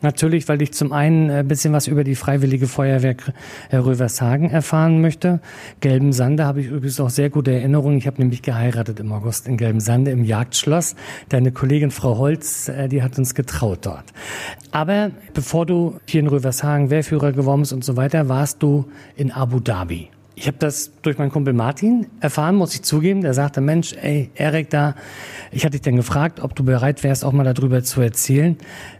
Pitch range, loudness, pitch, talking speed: 130-150 Hz, -19 LUFS, 140 Hz, 190 wpm